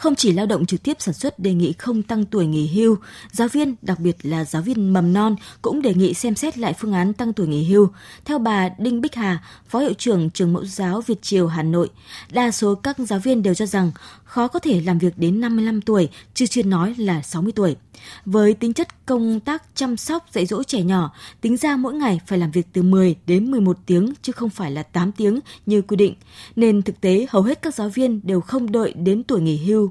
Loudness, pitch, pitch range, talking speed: -20 LUFS, 205 Hz, 180-235 Hz, 240 wpm